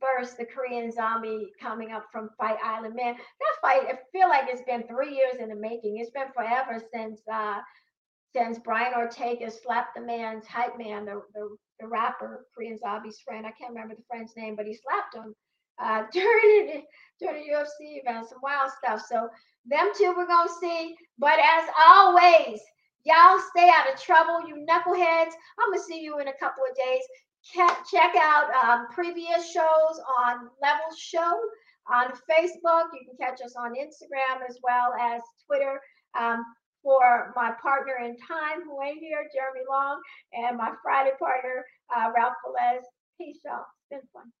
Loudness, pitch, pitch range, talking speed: -24 LUFS, 260 Hz, 235-325 Hz, 175 wpm